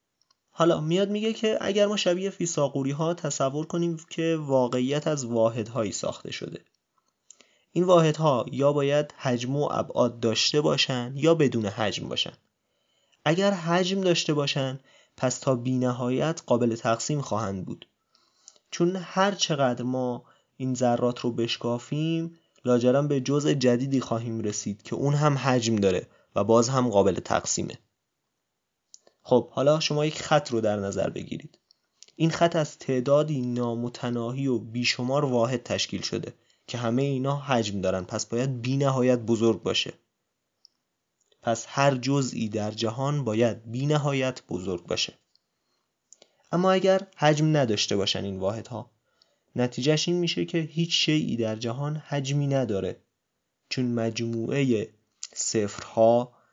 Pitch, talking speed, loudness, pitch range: 130 Hz, 135 wpm, -26 LUFS, 115-150 Hz